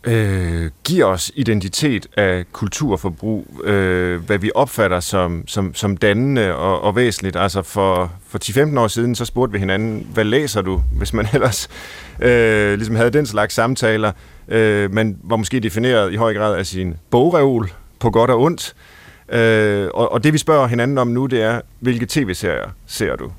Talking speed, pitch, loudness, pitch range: 175 wpm, 105 Hz, -17 LUFS, 95-120 Hz